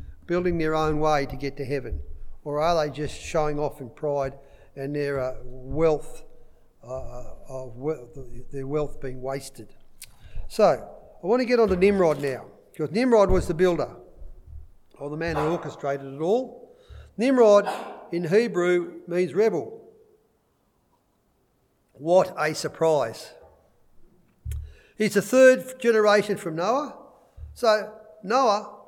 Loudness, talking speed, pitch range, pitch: -24 LUFS, 135 wpm, 135-205 Hz, 155 Hz